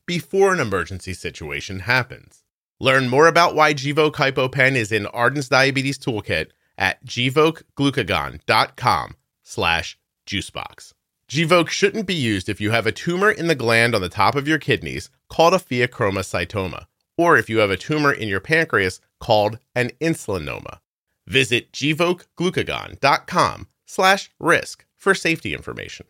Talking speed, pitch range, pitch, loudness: 135 wpm, 110-165 Hz, 135 Hz, -19 LUFS